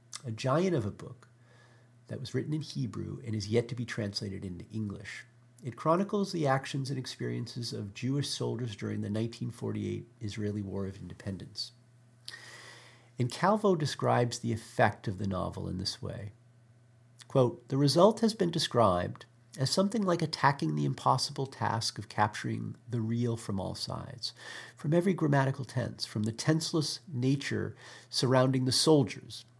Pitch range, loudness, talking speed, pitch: 110-135 Hz, -31 LUFS, 155 wpm, 120 Hz